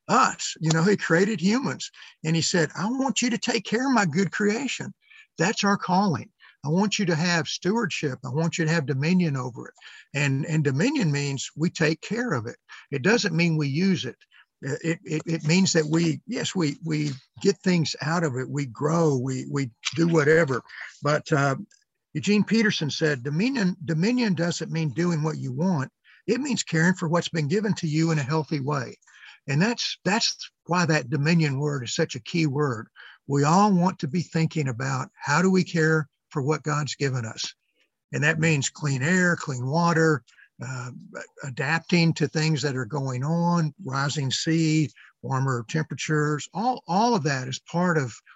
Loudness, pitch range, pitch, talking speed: -24 LUFS, 145-180 Hz, 160 Hz, 185 wpm